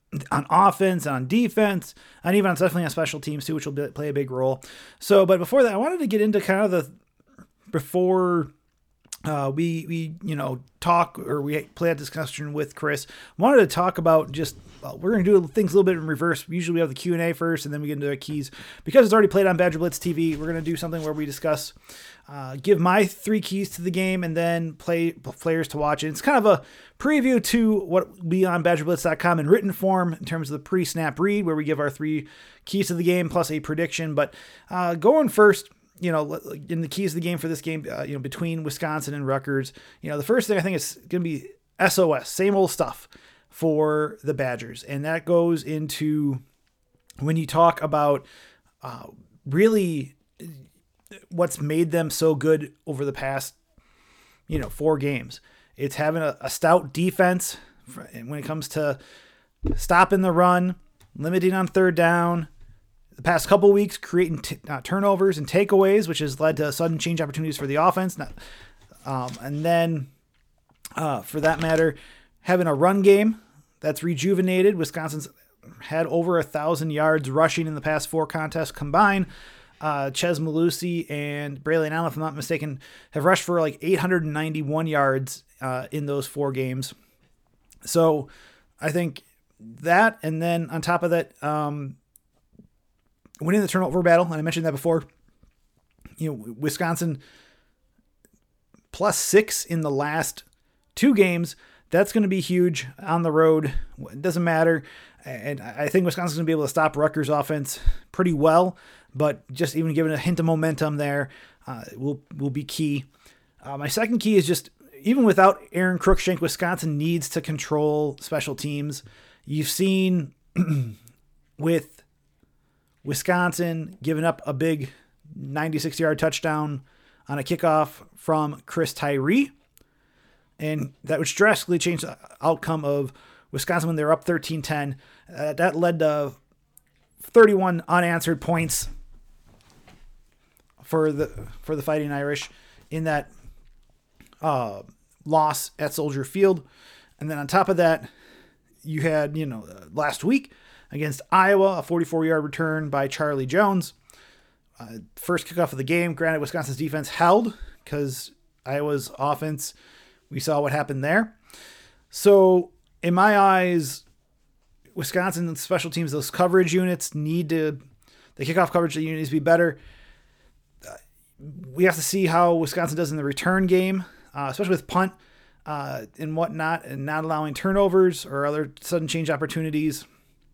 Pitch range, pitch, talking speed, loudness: 145-175 Hz, 160 Hz, 170 wpm, -23 LUFS